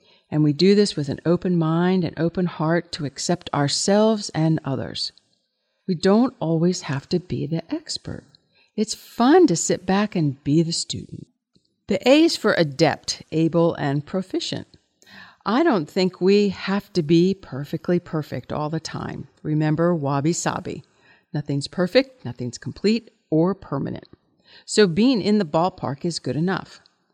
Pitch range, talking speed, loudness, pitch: 155-195 Hz, 150 wpm, -22 LUFS, 175 Hz